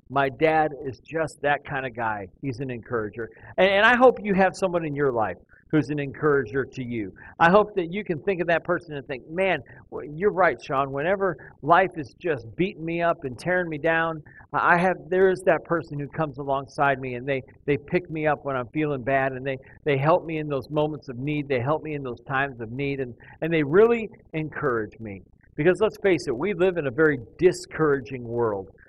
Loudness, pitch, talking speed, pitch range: -24 LUFS, 150 Hz, 225 wpm, 135-175 Hz